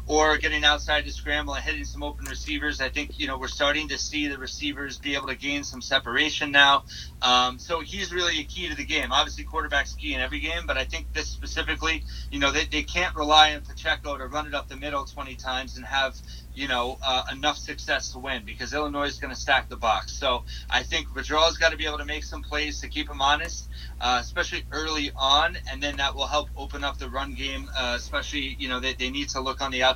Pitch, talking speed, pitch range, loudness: 140 Hz, 245 wpm, 125-150 Hz, -25 LUFS